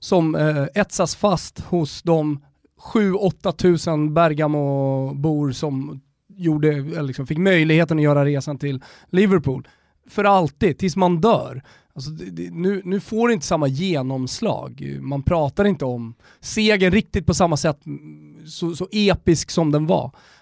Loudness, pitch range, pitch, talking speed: -20 LUFS, 140-185 Hz, 160 Hz, 145 wpm